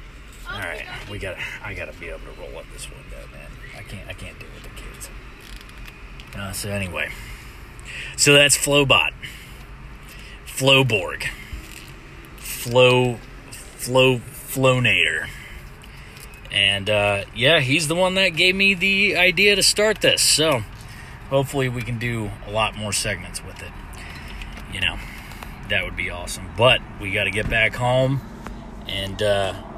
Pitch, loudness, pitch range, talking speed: 115 Hz, -19 LUFS, 100-135 Hz, 140 wpm